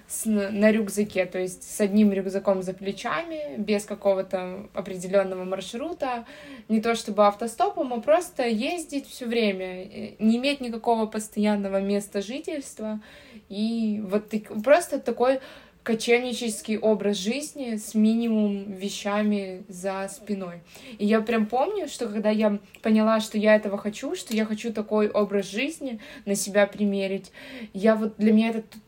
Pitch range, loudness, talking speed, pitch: 200-235 Hz, -25 LUFS, 145 wpm, 215 Hz